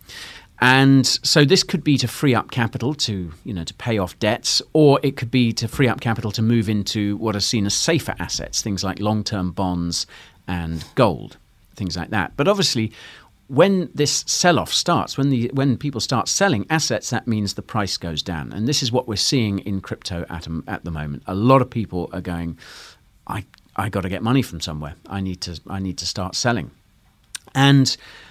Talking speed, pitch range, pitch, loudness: 205 wpm, 90-130 Hz, 110 Hz, -20 LUFS